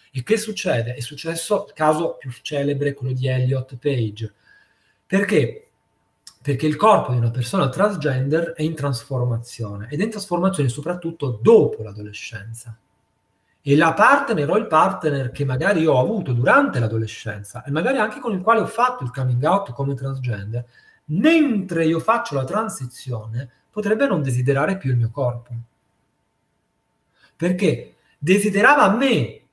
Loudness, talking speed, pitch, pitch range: -20 LUFS, 145 wpm, 140 Hz, 120-185 Hz